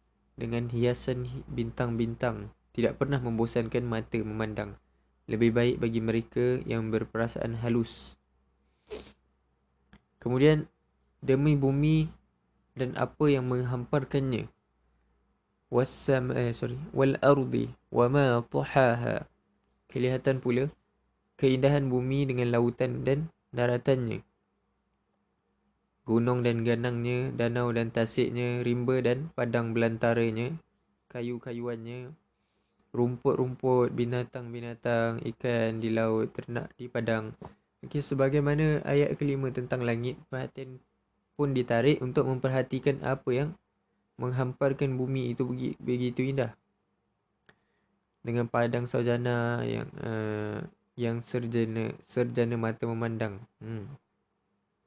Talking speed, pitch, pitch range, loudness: 95 wpm, 120 Hz, 115-130 Hz, -29 LUFS